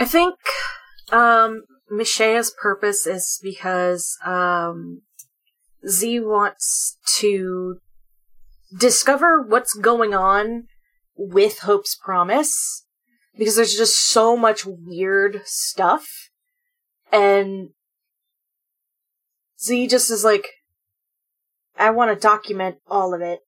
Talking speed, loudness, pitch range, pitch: 95 wpm, -18 LUFS, 185-240 Hz, 215 Hz